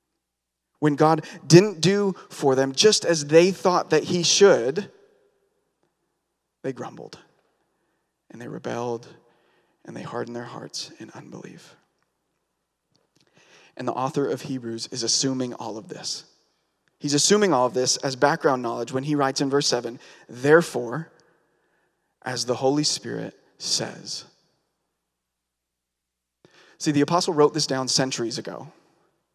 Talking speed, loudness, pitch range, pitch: 130 wpm, -22 LUFS, 120-160 Hz, 135 Hz